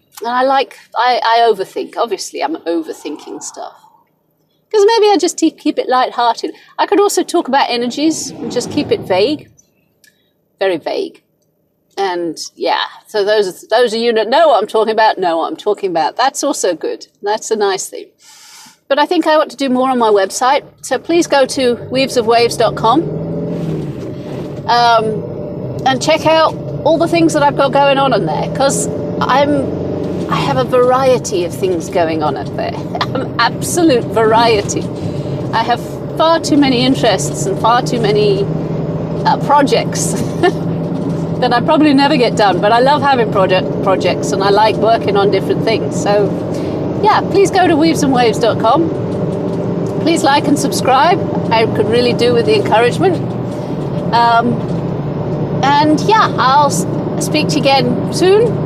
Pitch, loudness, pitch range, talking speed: 240 Hz, -13 LUFS, 190-305 Hz, 160 wpm